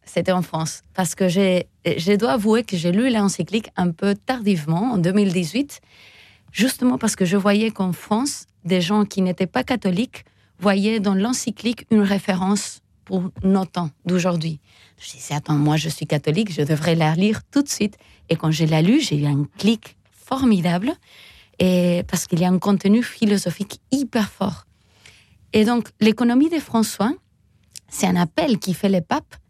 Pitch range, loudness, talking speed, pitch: 175-220 Hz, -20 LUFS, 175 wpm, 195 Hz